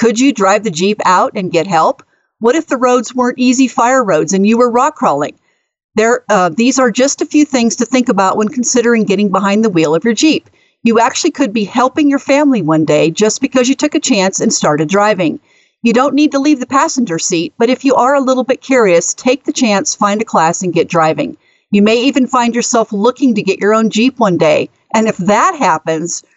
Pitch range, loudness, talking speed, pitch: 200-260 Hz, -12 LUFS, 230 wpm, 235 Hz